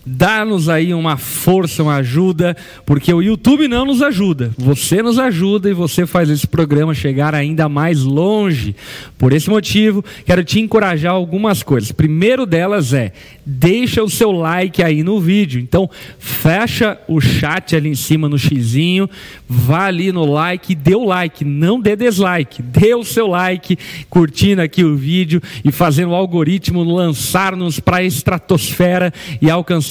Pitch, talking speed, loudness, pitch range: 175 Hz, 160 wpm, -14 LUFS, 150-190 Hz